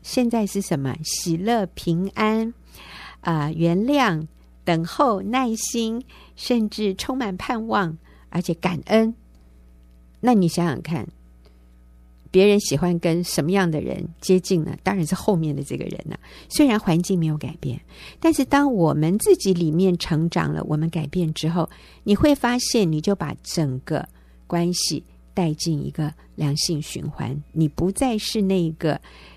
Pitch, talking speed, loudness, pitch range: 170 Hz, 220 characters per minute, -22 LUFS, 155-205 Hz